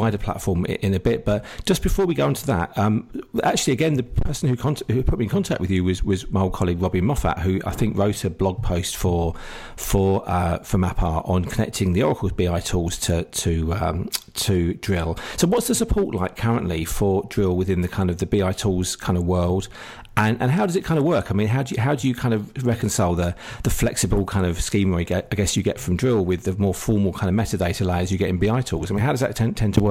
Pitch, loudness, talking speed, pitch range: 100 Hz, -22 LUFS, 255 wpm, 90-115 Hz